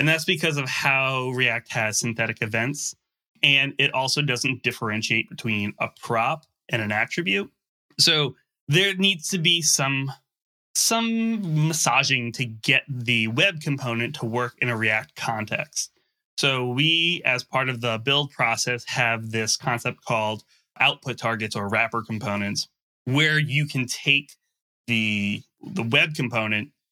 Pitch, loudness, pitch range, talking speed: 130 Hz, -22 LUFS, 115-150 Hz, 145 wpm